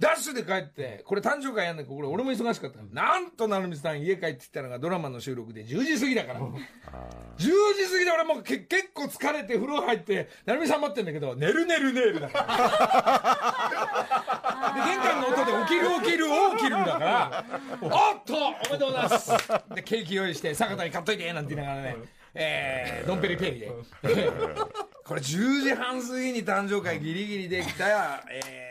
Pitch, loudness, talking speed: 205 Hz, -27 LUFS, 365 characters per minute